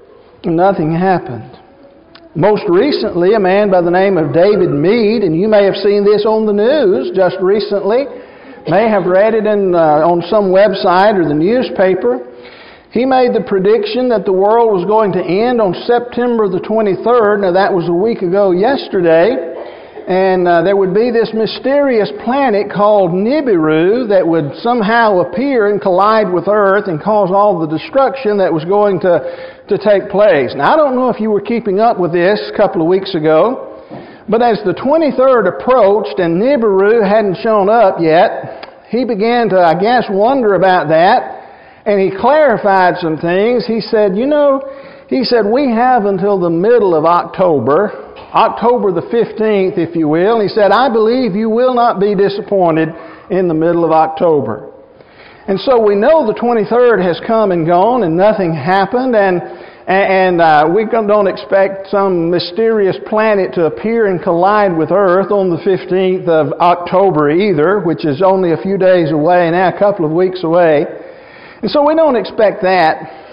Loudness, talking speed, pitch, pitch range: -12 LUFS, 175 wpm, 200 Hz, 180-225 Hz